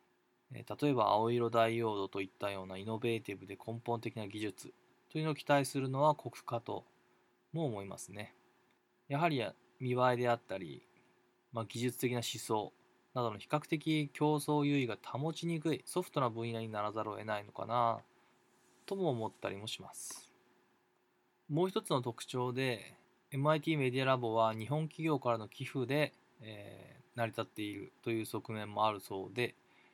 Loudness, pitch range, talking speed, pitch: -37 LUFS, 110-140 Hz, 320 characters per minute, 120 Hz